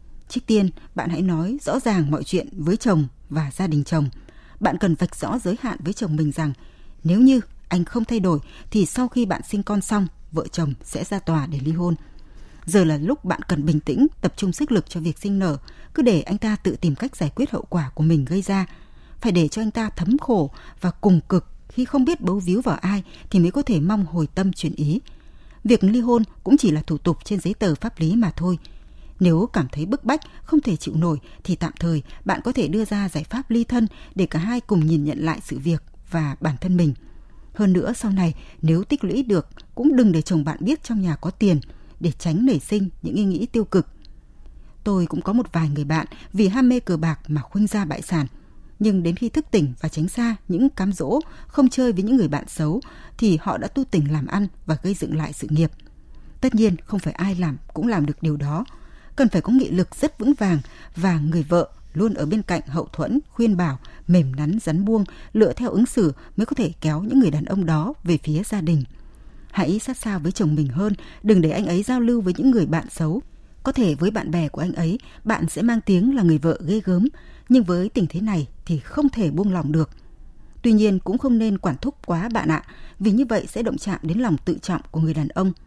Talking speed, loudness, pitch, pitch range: 245 wpm, -22 LUFS, 185 Hz, 160-220 Hz